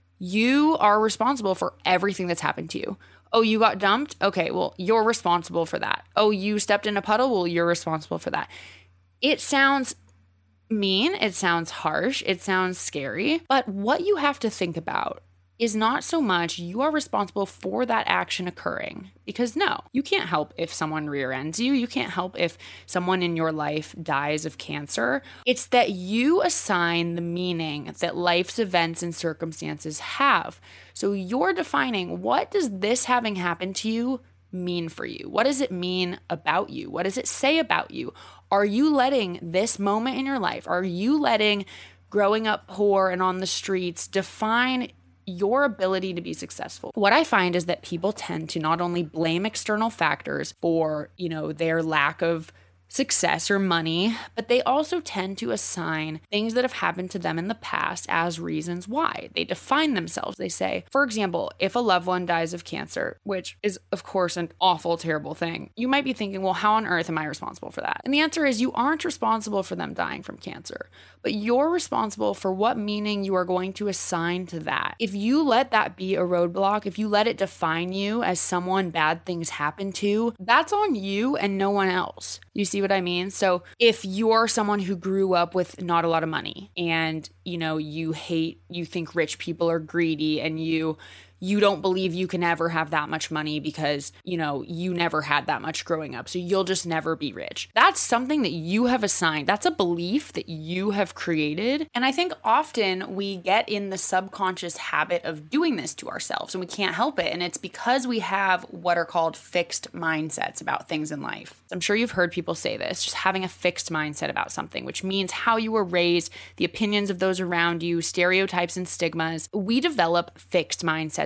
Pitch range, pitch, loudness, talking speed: 165-220 Hz, 185 Hz, -25 LUFS, 200 wpm